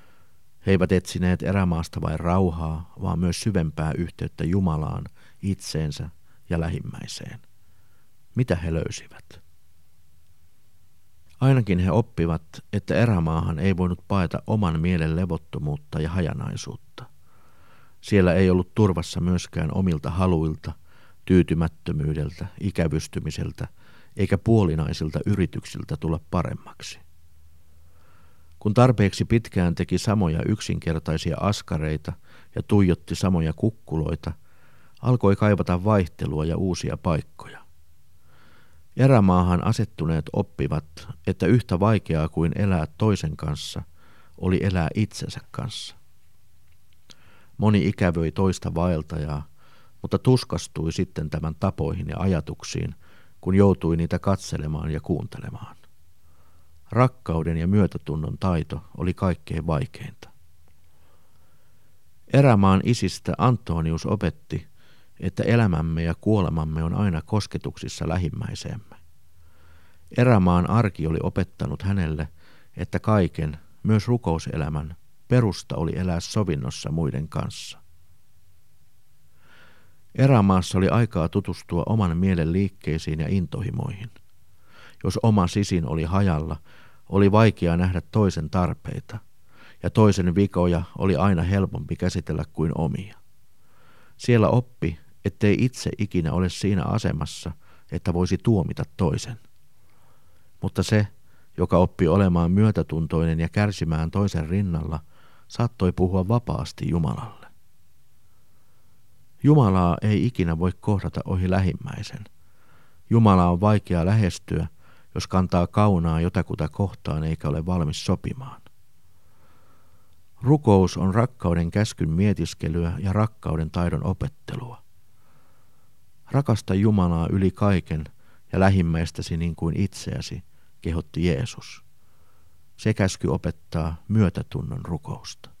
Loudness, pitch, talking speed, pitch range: -24 LUFS, 90 Hz, 100 wpm, 80-100 Hz